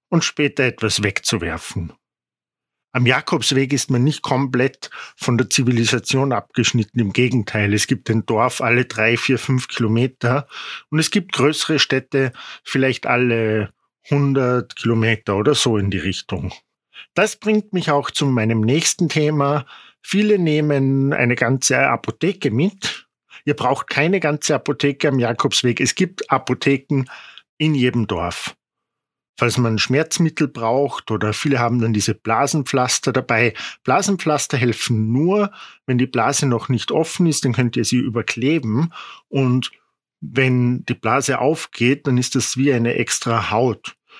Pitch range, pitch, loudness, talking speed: 115-145 Hz, 130 Hz, -18 LUFS, 140 wpm